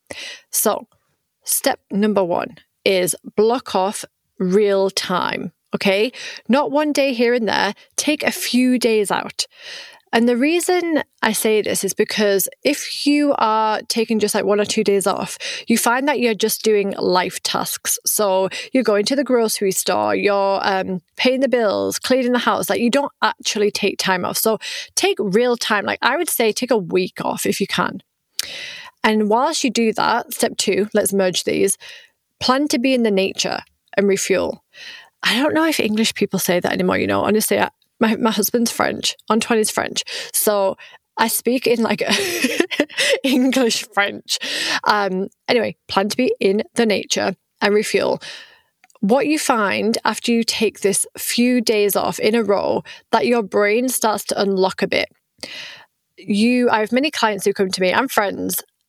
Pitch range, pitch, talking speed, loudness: 205-270 Hz, 225 Hz, 175 wpm, -18 LUFS